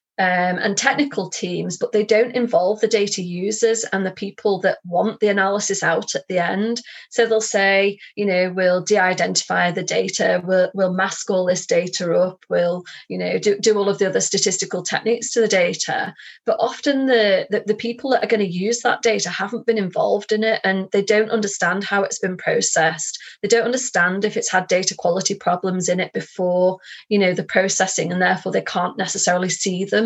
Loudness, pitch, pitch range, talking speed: -19 LUFS, 195 Hz, 185-215 Hz, 205 wpm